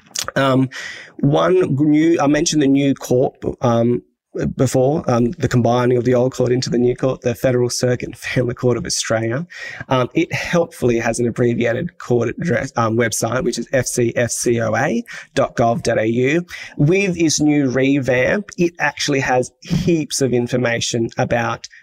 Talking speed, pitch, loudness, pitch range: 145 wpm, 125 Hz, -18 LUFS, 120-145 Hz